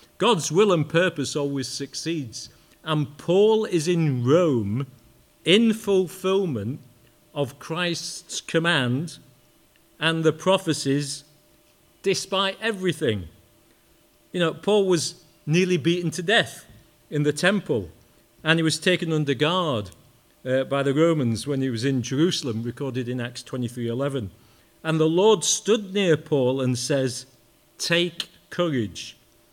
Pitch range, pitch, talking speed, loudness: 130-175 Hz, 150 Hz, 125 wpm, -23 LUFS